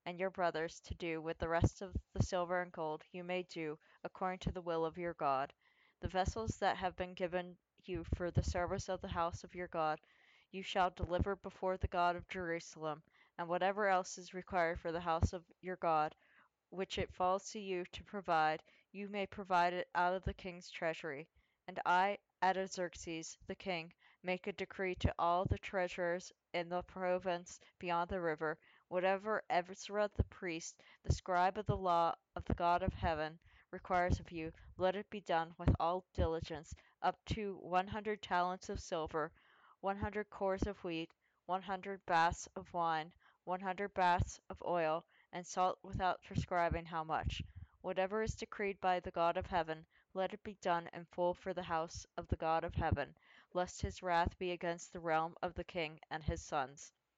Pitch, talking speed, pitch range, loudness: 180 Hz, 190 wpm, 170-190 Hz, -39 LUFS